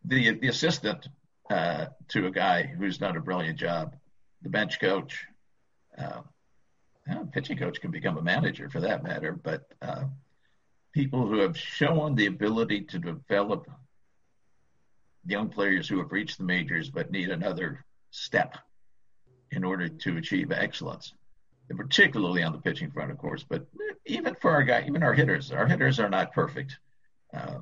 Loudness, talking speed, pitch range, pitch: -28 LUFS, 160 wpm, 105-150 Hz, 135 Hz